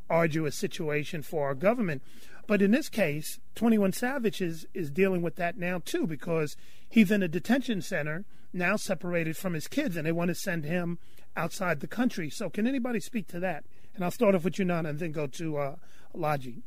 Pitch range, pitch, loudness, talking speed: 160-205 Hz, 180 Hz, -30 LUFS, 205 wpm